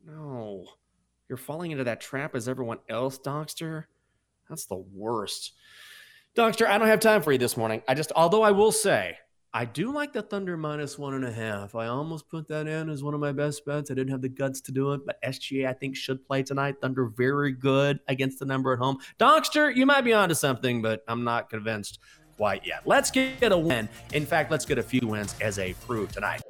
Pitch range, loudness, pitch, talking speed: 125-165 Hz, -26 LUFS, 140 Hz, 225 wpm